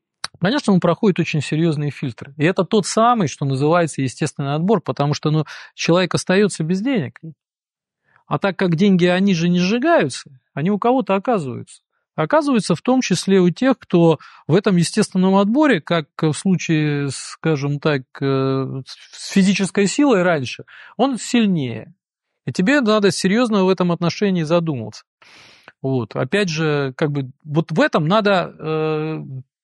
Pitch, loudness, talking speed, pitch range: 175 Hz, -18 LUFS, 150 wpm, 150-200 Hz